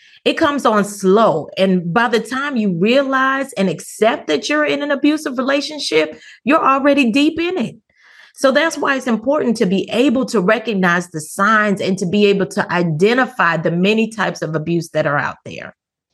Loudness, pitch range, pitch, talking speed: -16 LUFS, 190-275 Hz, 225 Hz, 185 wpm